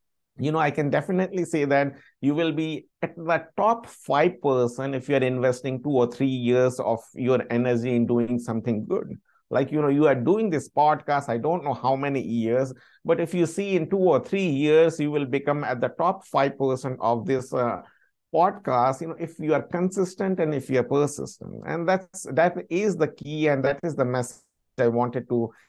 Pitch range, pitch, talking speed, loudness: 125-165 Hz, 145 Hz, 210 wpm, -24 LUFS